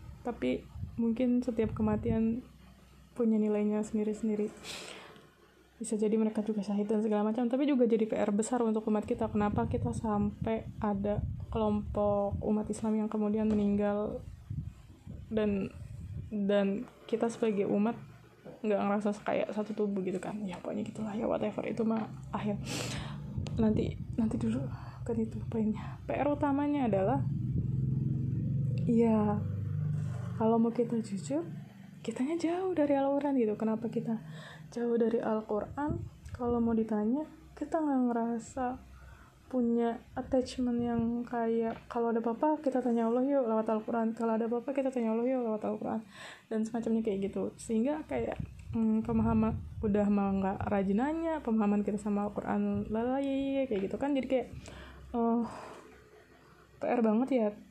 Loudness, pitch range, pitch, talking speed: -32 LUFS, 205-240 Hz, 220 Hz, 140 wpm